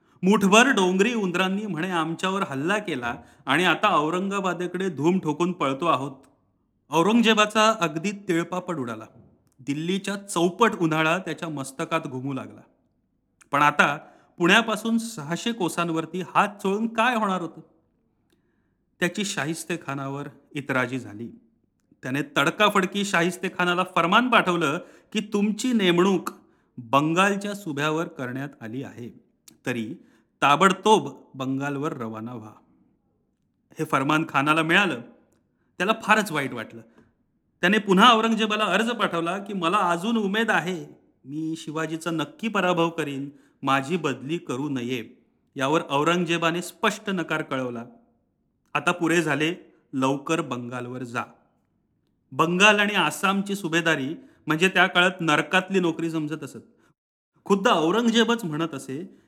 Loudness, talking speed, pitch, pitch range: -23 LUFS, 110 wpm, 170 Hz, 140-195 Hz